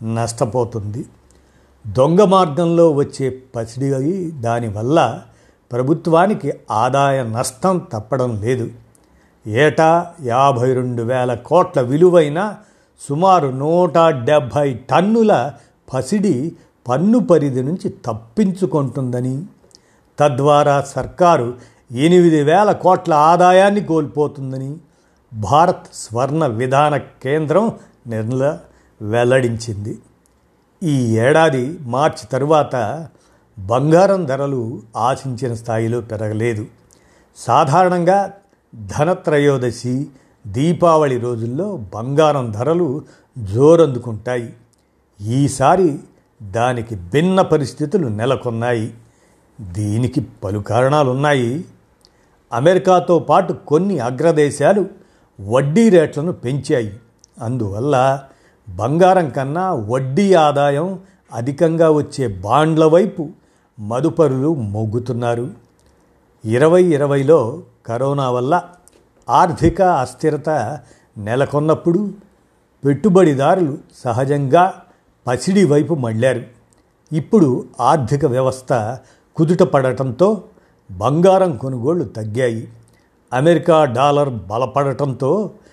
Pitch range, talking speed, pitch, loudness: 120-165 Hz, 75 wpm, 140 Hz, -16 LUFS